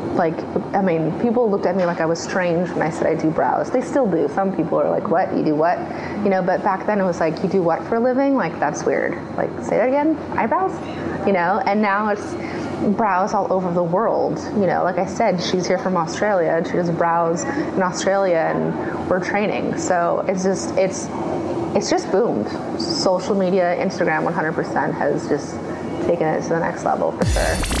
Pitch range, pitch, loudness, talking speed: 175-200 Hz, 185 Hz, -20 LUFS, 215 wpm